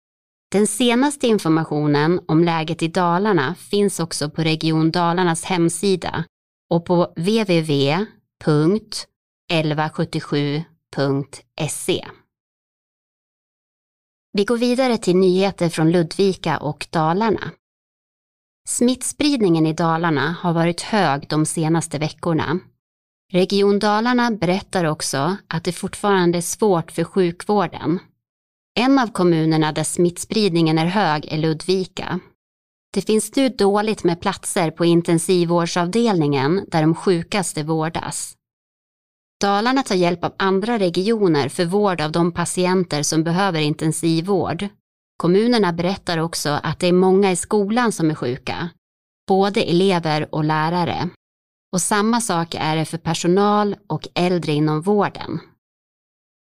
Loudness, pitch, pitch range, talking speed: -19 LUFS, 175 Hz, 160-195 Hz, 115 wpm